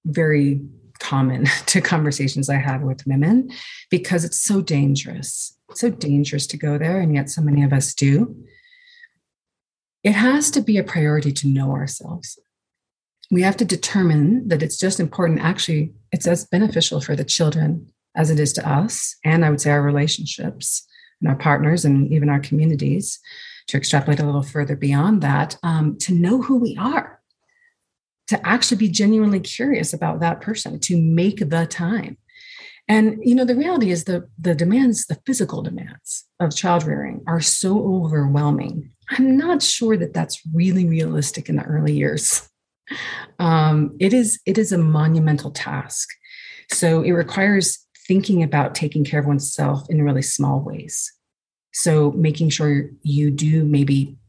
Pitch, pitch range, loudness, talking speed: 165 Hz, 145-200 Hz, -19 LUFS, 165 wpm